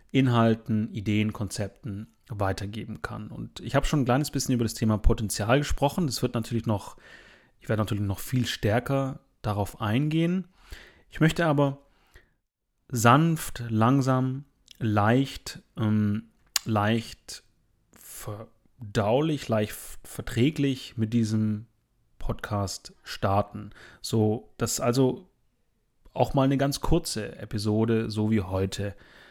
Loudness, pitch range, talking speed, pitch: -27 LUFS, 105-135 Hz, 115 wpm, 115 Hz